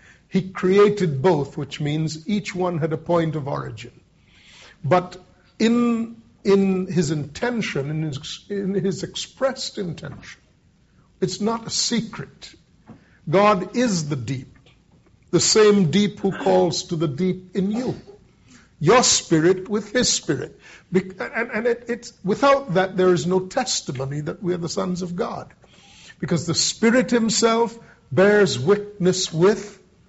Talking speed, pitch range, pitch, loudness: 140 wpm, 170-210 Hz, 185 Hz, -21 LUFS